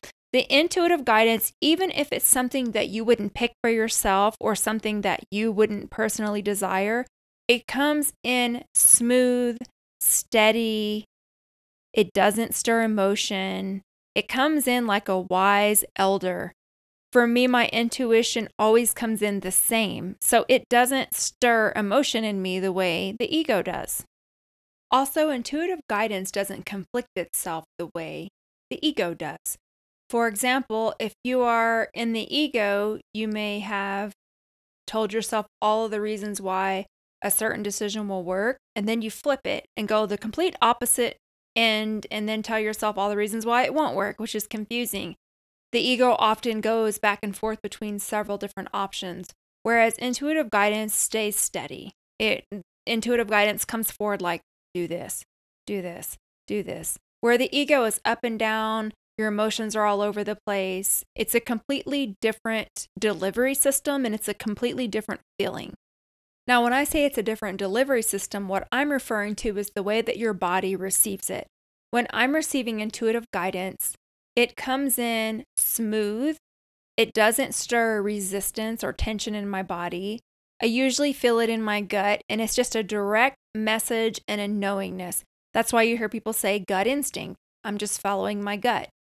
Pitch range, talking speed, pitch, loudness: 205-240 Hz, 160 wpm, 220 Hz, -24 LUFS